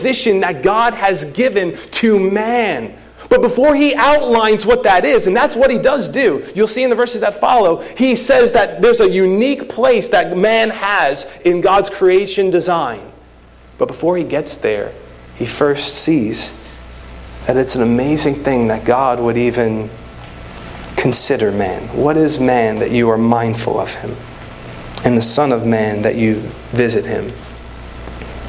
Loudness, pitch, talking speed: -14 LUFS, 155 Hz, 160 wpm